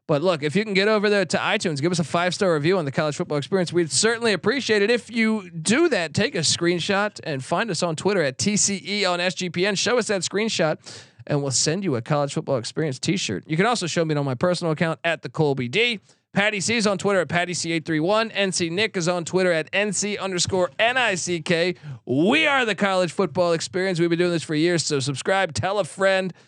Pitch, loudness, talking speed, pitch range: 180 Hz, -22 LUFS, 240 wpm, 160-200 Hz